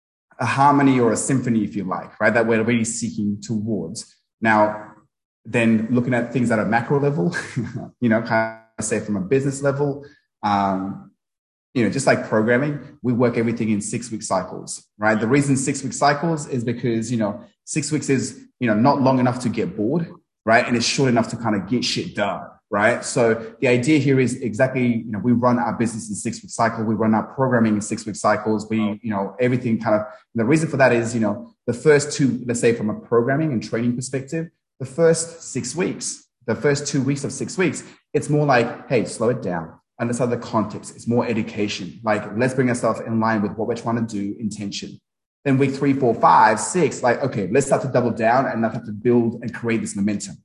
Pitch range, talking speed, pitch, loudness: 110-130 Hz, 220 wpm, 115 Hz, -21 LUFS